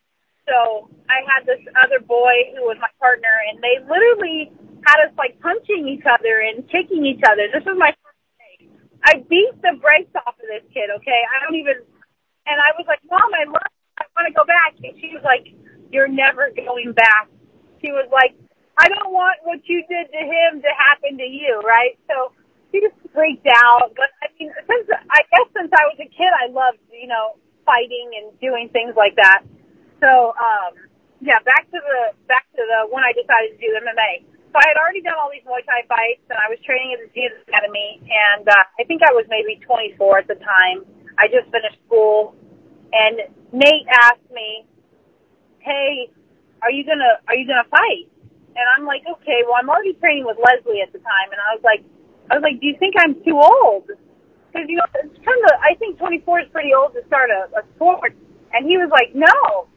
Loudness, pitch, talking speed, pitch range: -15 LUFS, 270 Hz, 210 wpm, 235-320 Hz